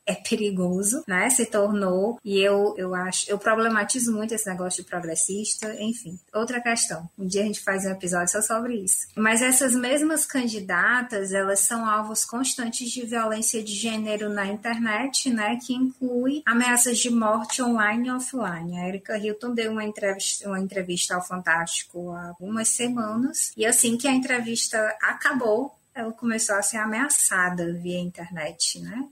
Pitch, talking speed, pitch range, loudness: 215 Hz, 165 wpm, 195-235 Hz, -24 LUFS